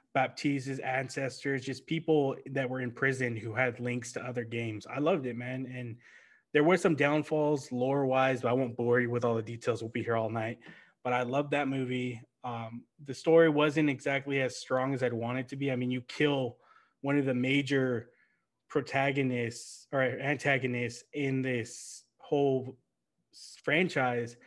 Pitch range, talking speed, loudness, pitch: 120-140 Hz, 175 wpm, -31 LUFS, 130 Hz